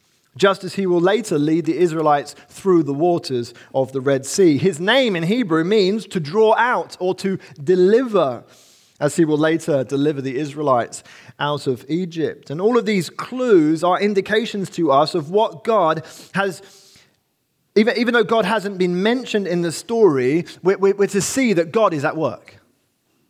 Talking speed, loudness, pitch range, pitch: 170 wpm, -19 LUFS, 150-205 Hz, 180 Hz